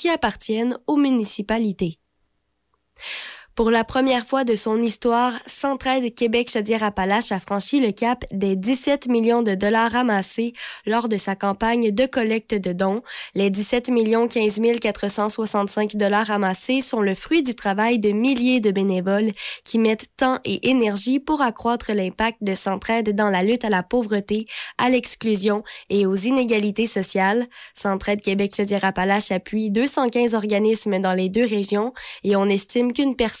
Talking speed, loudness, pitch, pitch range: 145 wpm, -21 LUFS, 220 Hz, 200-245 Hz